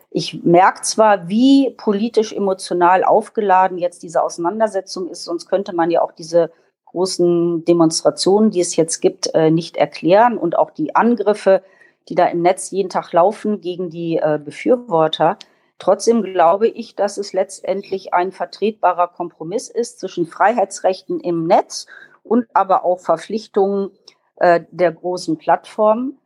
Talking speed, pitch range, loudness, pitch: 135 wpm, 170-210 Hz, -17 LUFS, 185 Hz